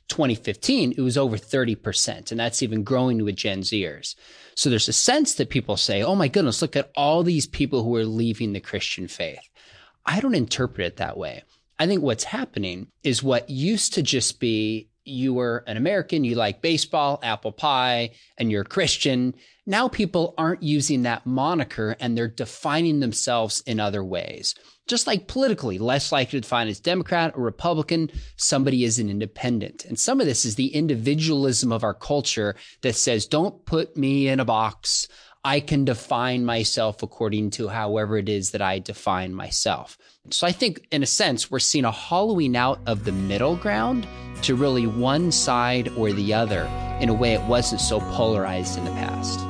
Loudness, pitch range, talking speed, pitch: -23 LUFS, 110-140 Hz, 185 wpm, 120 Hz